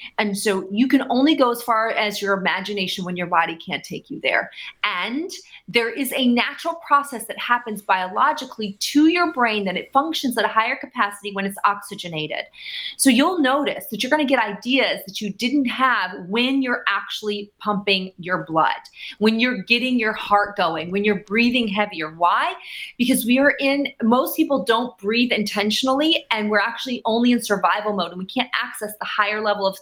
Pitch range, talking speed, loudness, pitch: 200-260 Hz, 190 wpm, -21 LUFS, 225 Hz